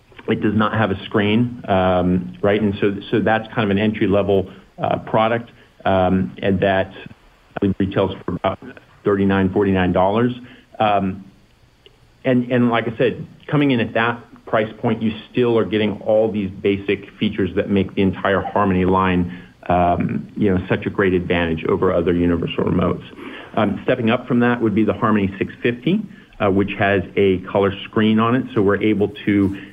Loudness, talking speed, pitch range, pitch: -19 LUFS, 180 wpm, 95-115 Hz, 100 Hz